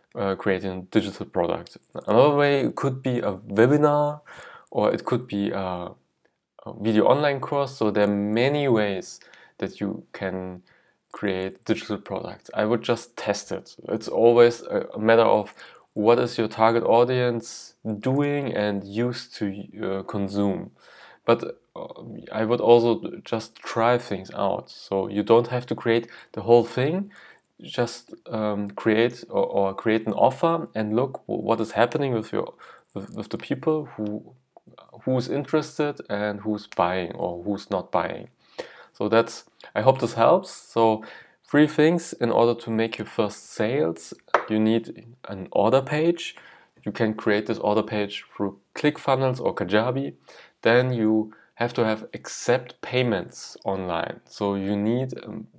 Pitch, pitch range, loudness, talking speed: 115 Hz, 105-125 Hz, -24 LUFS, 155 wpm